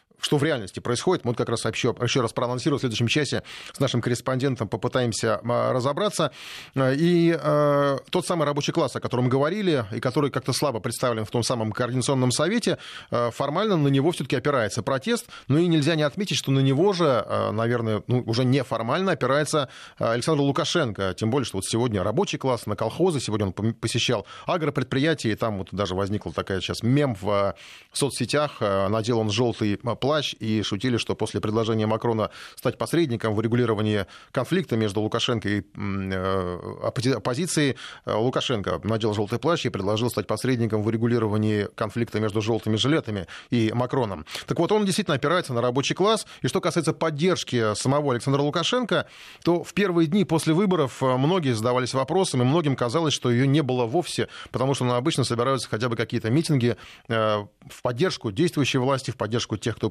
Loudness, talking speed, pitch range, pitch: -24 LUFS, 170 wpm, 110-150 Hz, 125 Hz